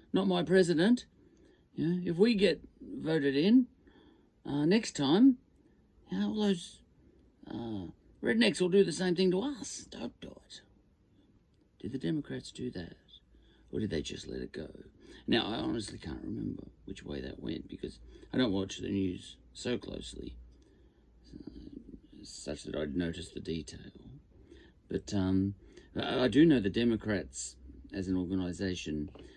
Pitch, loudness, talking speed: 105 Hz, -32 LUFS, 150 wpm